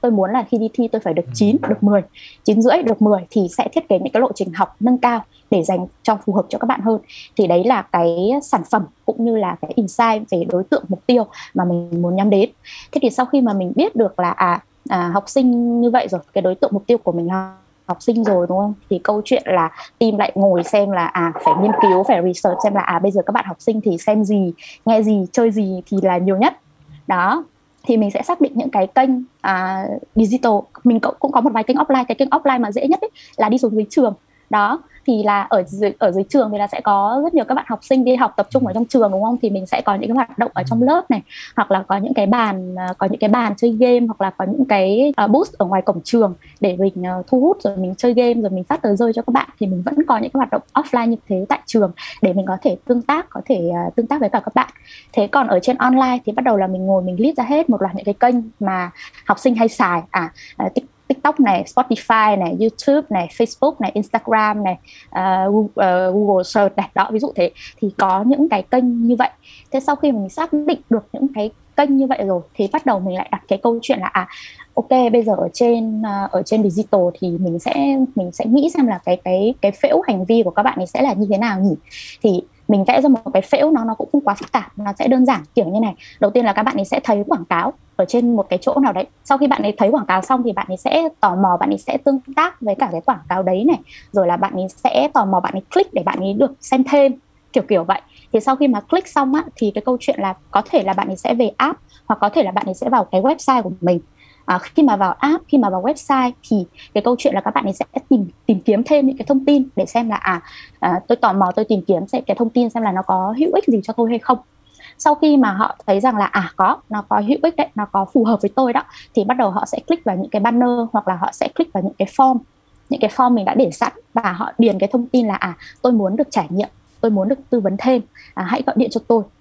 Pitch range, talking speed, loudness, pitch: 195-260 Hz, 280 wpm, -17 LUFS, 220 Hz